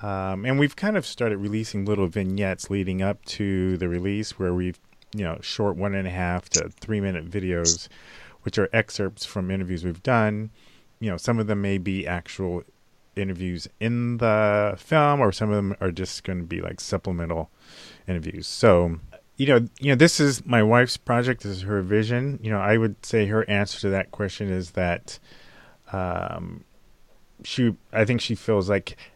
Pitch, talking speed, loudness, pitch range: 100 Hz, 185 wpm, -24 LUFS, 95-110 Hz